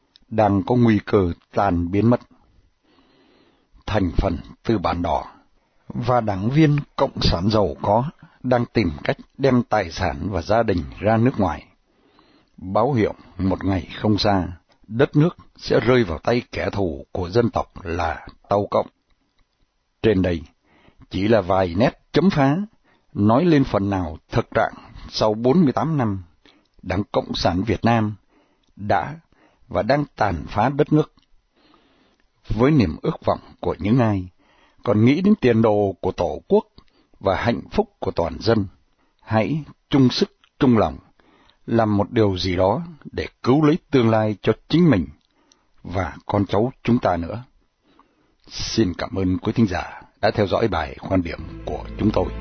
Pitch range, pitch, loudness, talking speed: 95-125 Hz, 105 Hz, -21 LUFS, 160 wpm